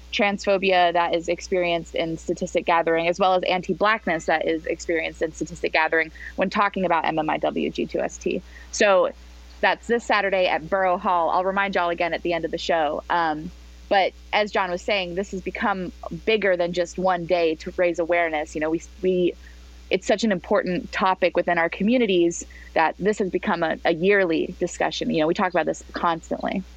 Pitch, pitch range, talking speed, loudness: 180 Hz, 165-195 Hz, 185 wpm, -23 LUFS